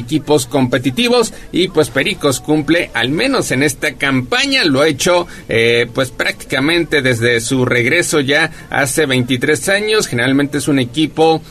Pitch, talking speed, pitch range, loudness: 150 Hz, 145 wpm, 130-165 Hz, -14 LUFS